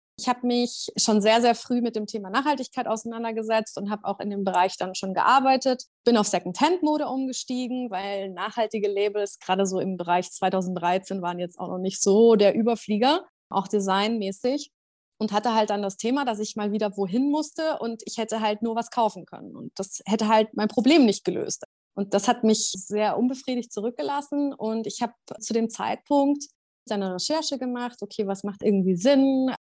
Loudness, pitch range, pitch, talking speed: -25 LUFS, 200-250 Hz, 220 Hz, 185 wpm